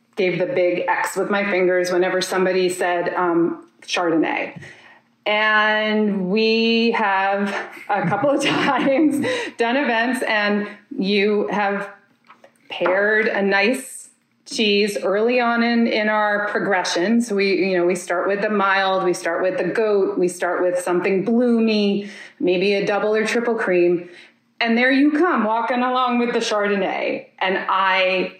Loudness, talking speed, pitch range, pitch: -19 LUFS, 150 wpm, 185-235 Hz, 205 Hz